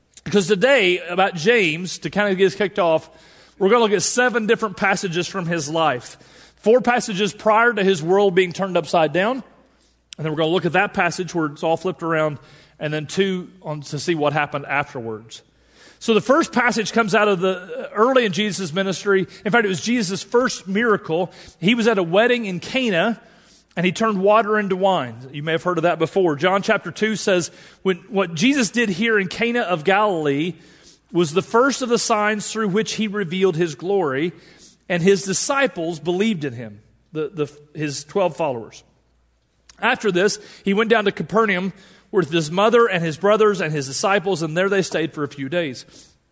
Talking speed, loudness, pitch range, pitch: 200 wpm, -19 LUFS, 165-215 Hz, 190 Hz